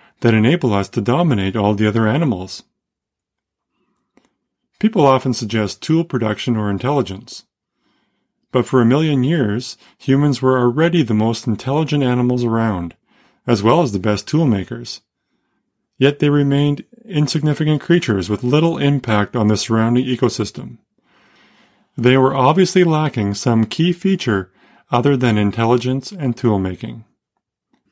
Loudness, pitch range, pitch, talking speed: -17 LUFS, 110-145 Hz, 125 Hz, 130 wpm